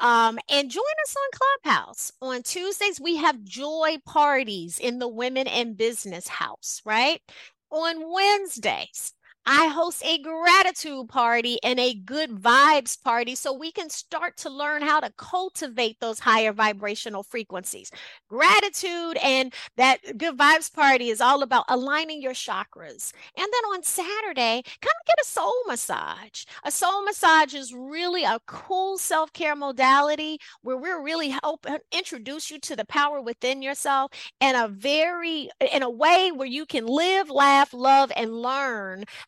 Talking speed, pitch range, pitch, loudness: 150 wpm, 250-325 Hz, 285 Hz, -23 LUFS